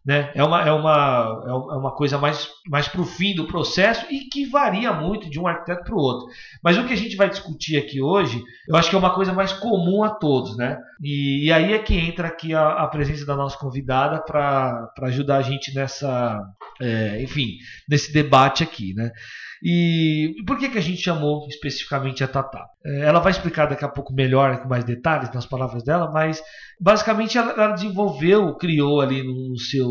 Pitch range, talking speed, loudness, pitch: 135-175 Hz, 205 wpm, -21 LUFS, 150 Hz